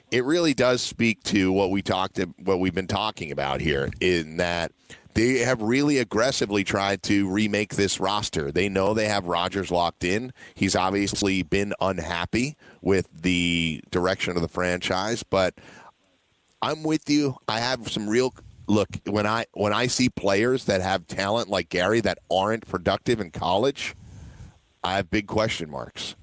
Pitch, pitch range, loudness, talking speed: 100 Hz, 95-110 Hz, -24 LUFS, 165 wpm